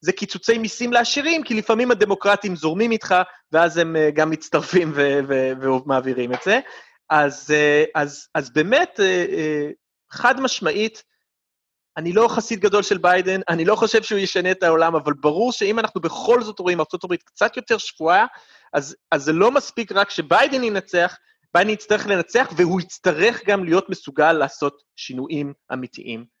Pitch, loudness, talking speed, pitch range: 180 Hz, -19 LUFS, 165 wpm, 155-215 Hz